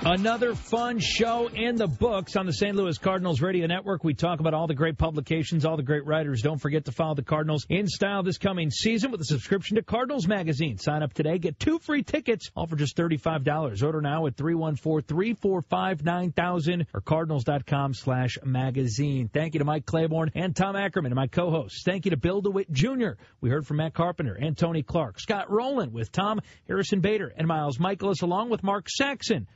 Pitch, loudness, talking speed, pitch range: 165 Hz, -27 LUFS, 195 wpm, 150-195 Hz